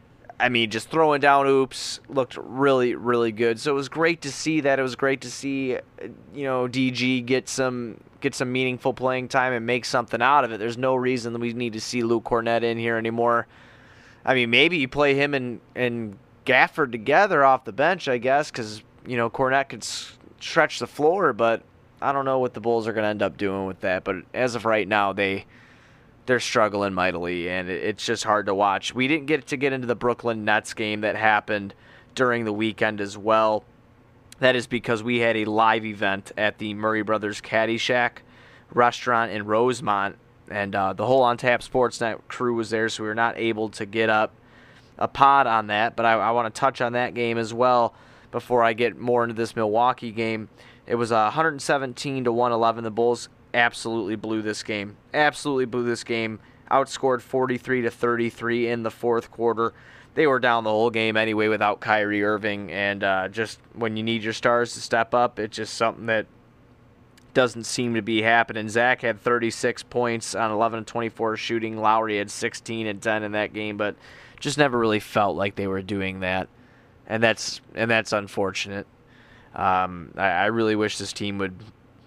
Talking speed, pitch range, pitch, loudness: 200 wpm, 110-125 Hz, 115 Hz, -23 LUFS